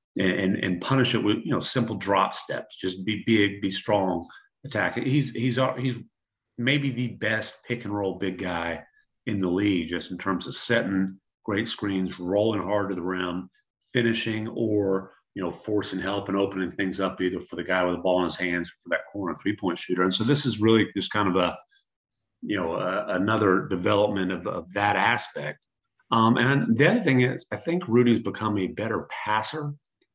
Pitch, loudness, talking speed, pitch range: 105 Hz, -26 LUFS, 200 wpm, 95-115 Hz